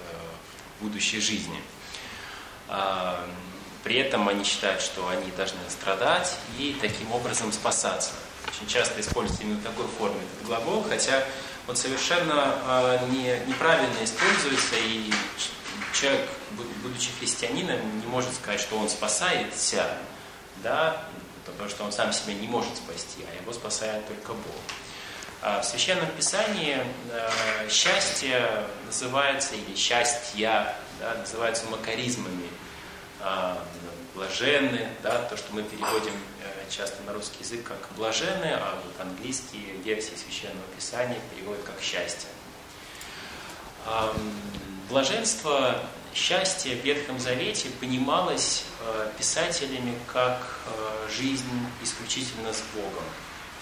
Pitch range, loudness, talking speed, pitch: 105-125 Hz, -27 LUFS, 105 wpm, 110 Hz